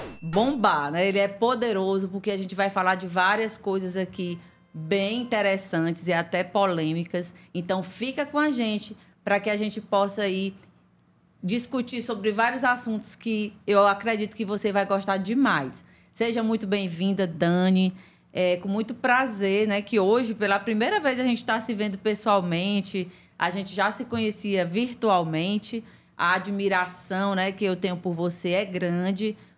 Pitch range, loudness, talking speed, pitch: 185-220 Hz, -25 LUFS, 160 wpm, 200 Hz